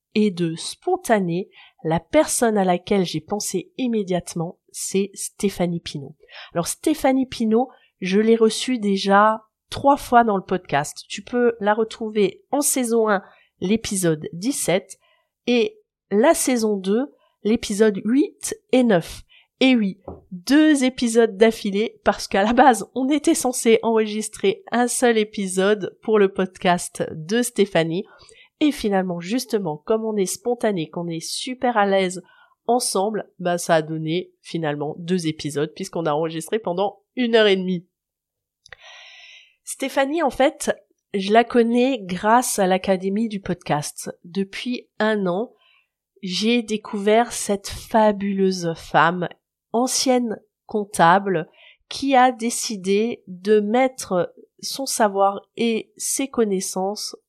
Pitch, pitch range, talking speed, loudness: 215 Hz, 190-250 Hz, 130 wpm, -21 LUFS